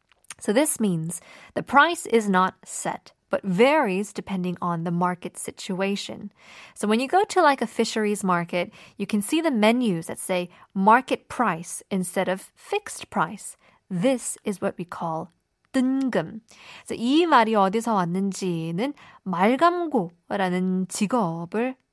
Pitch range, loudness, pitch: 185-250 Hz, -24 LUFS, 205 Hz